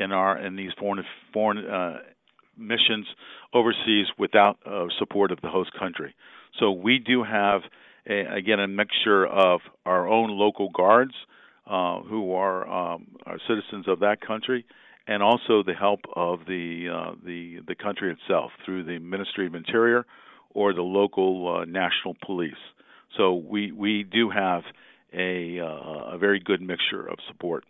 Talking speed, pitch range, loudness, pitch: 160 wpm, 90-105 Hz, -25 LUFS, 100 Hz